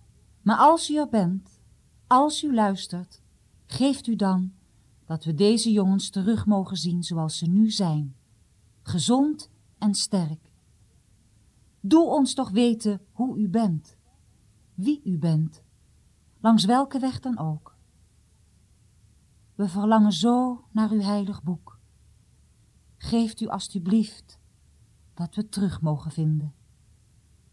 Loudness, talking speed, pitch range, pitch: -24 LUFS, 120 wpm, 155-225 Hz, 195 Hz